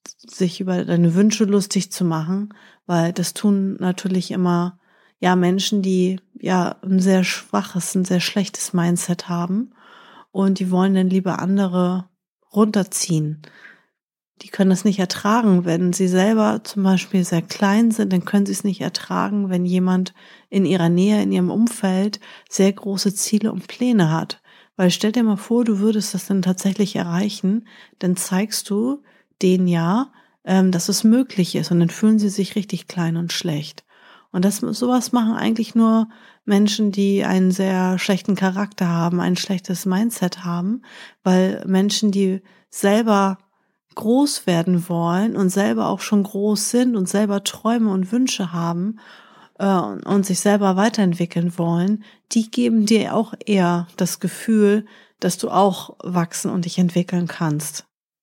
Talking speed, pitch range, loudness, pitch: 155 wpm, 180-215 Hz, -19 LUFS, 195 Hz